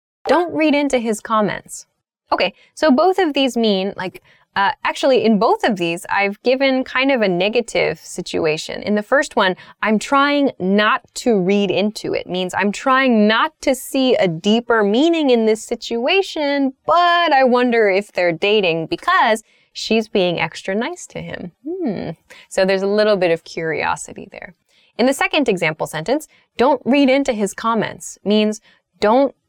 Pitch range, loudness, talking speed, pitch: 195-275 Hz, -17 LUFS, 165 wpm, 225 Hz